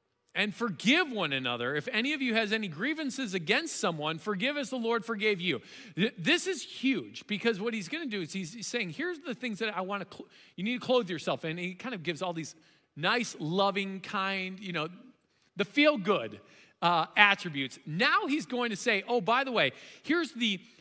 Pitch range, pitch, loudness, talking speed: 185-250 Hz, 215 Hz, -30 LUFS, 210 wpm